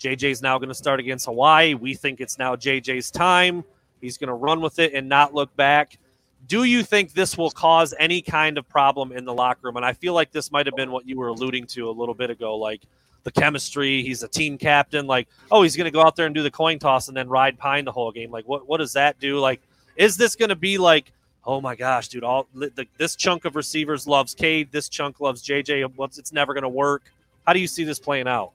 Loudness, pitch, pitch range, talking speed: -21 LUFS, 140 Hz, 130-155 Hz, 255 wpm